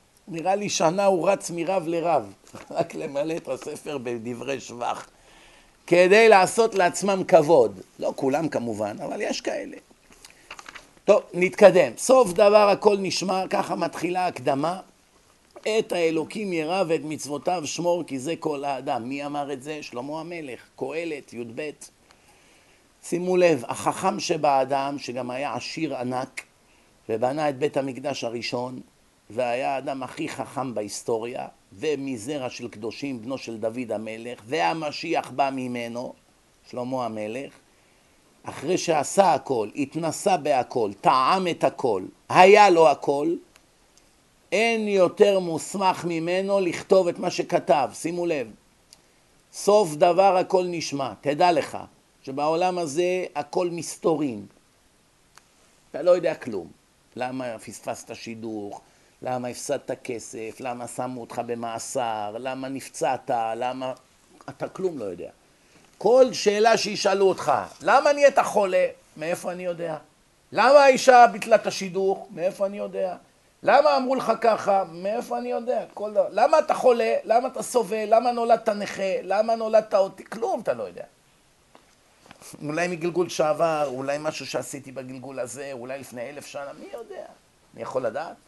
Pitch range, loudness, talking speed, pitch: 130-195 Hz, -23 LUFS, 130 wpm, 165 Hz